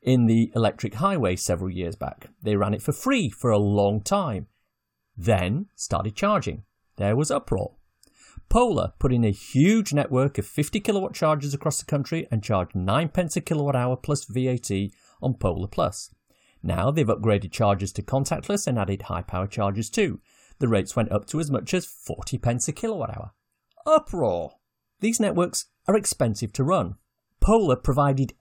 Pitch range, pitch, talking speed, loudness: 105-160 Hz, 125 Hz, 170 wpm, -25 LUFS